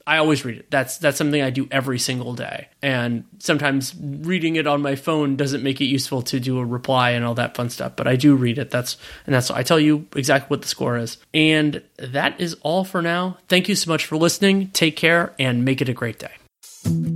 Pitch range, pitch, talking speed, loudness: 125-160 Hz, 140 Hz, 240 wpm, -20 LUFS